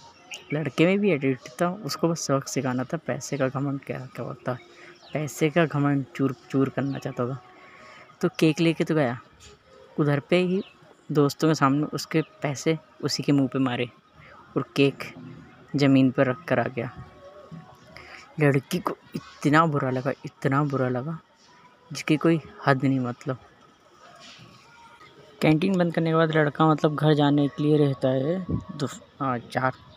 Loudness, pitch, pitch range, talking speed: -25 LUFS, 145 Hz, 135-160 Hz, 150 wpm